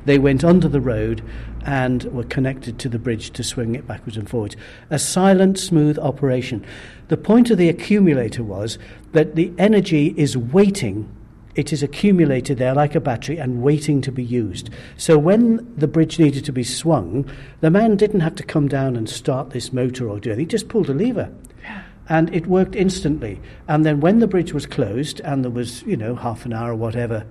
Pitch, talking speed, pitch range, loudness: 140 Hz, 200 wpm, 120-160 Hz, -19 LUFS